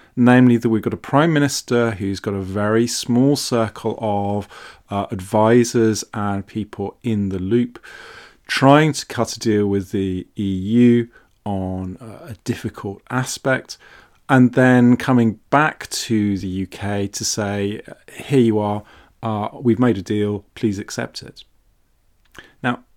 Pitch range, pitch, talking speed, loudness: 100-120 Hz, 110 Hz, 140 wpm, -19 LUFS